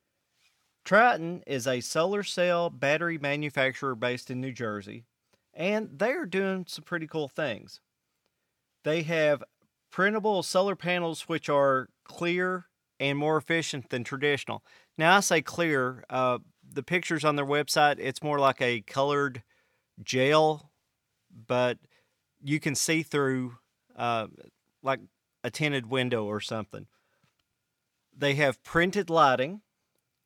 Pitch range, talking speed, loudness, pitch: 125-165 Hz, 125 wpm, -28 LUFS, 145 Hz